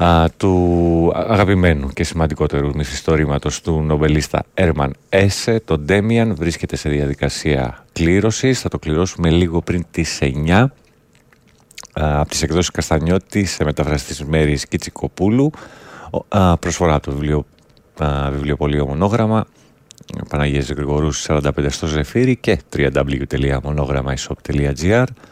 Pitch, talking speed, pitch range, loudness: 80 Hz, 110 wpm, 75-90 Hz, -18 LUFS